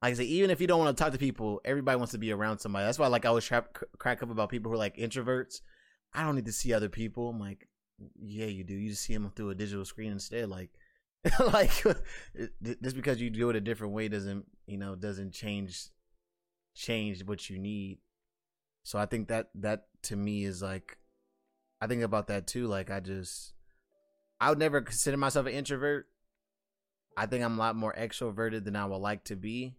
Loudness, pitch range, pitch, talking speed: -33 LUFS, 100-120 Hz, 110 Hz, 220 wpm